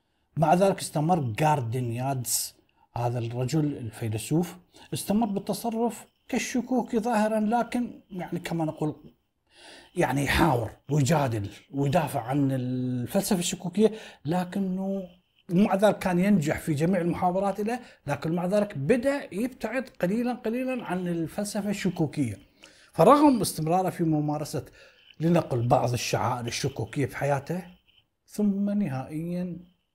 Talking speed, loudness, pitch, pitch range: 105 wpm, -27 LUFS, 170 Hz, 140-205 Hz